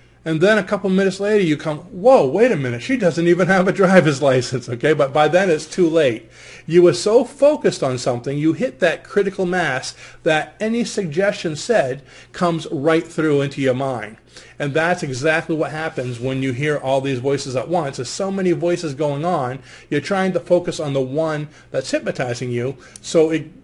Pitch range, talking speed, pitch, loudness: 135-185 Hz, 200 wpm, 160 Hz, -19 LUFS